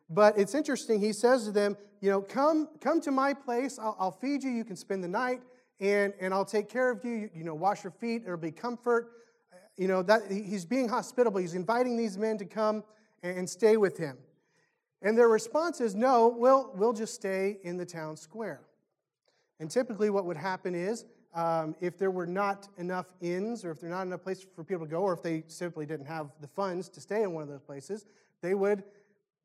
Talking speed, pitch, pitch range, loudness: 220 wpm, 200 Hz, 180-230 Hz, -30 LUFS